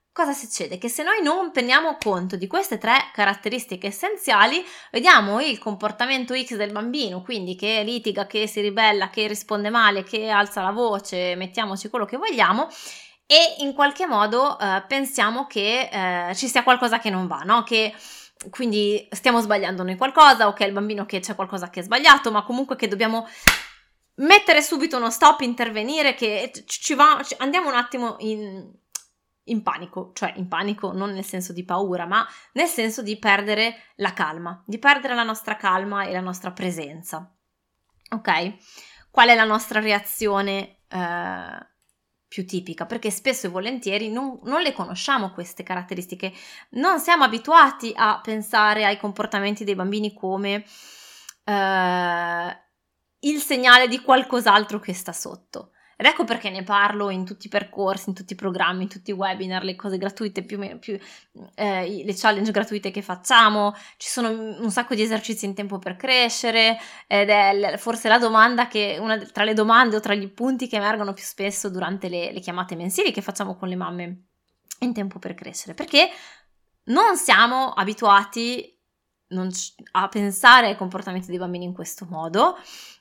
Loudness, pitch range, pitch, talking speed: -20 LUFS, 195-240 Hz, 210 Hz, 170 wpm